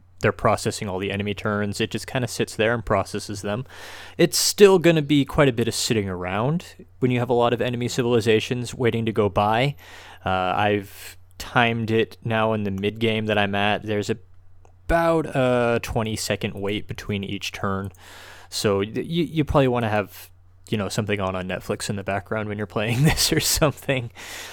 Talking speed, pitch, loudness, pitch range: 195 wpm, 110 Hz, -22 LUFS, 100-120 Hz